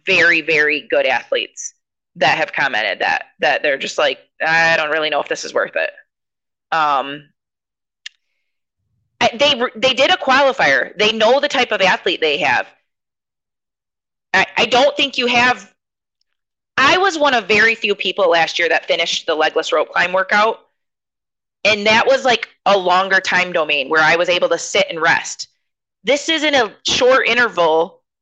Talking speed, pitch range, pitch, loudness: 165 wpm, 170-265 Hz, 215 Hz, -15 LUFS